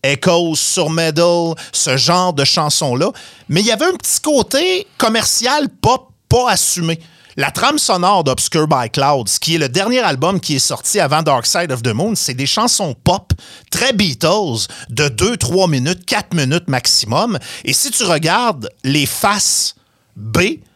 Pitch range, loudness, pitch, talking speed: 135-190 Hz, -14 LUFS, 165 Hz, 165 wpm